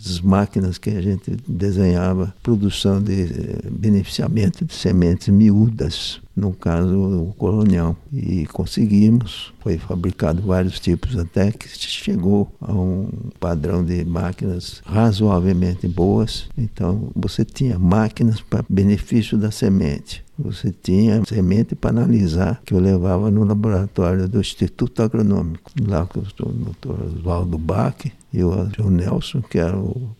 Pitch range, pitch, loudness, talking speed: 90-110 Hz, 100 Hz, -19 LUFS, 130 wpm